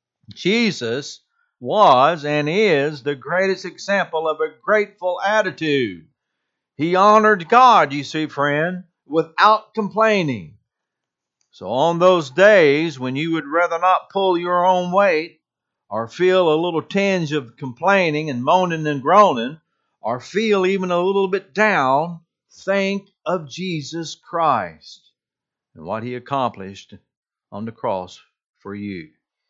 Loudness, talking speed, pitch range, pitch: -18 LUFS, 130 wpm, 150-195 Hz, 175 Hz